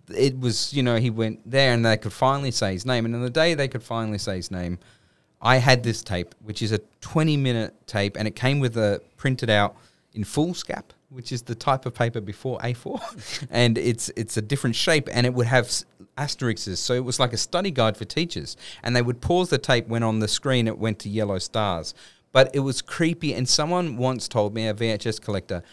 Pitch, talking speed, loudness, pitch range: 120 Hz, 230 wpm, -24 LUFS, 110-130 Hz